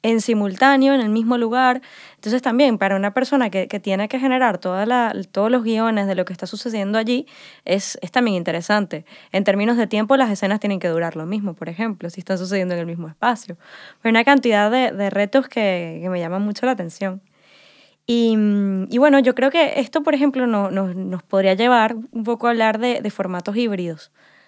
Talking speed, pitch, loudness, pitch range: 210 wpm, 215 Hz, -19 LUFS, 195-250 Hz